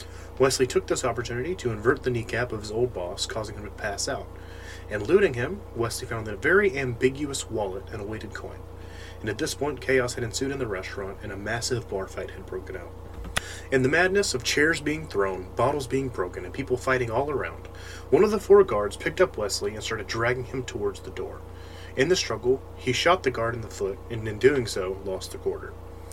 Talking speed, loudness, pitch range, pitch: 220 wpm, -26 LUFS, 95-130 Hz, 110 Hz